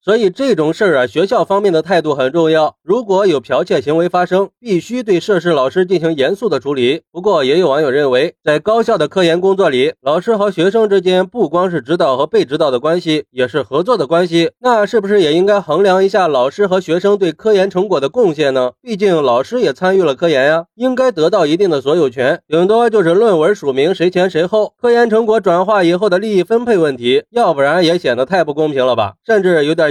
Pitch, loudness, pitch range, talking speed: 185 Hz, -13 LUFS, 165-220 Hz, 345 characters per minute